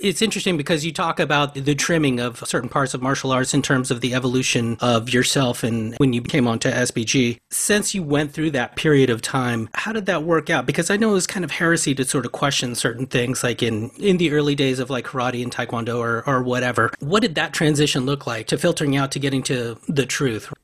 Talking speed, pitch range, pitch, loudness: 240 wpm, 125-160 Hz, 135 Hz, -20 LUFS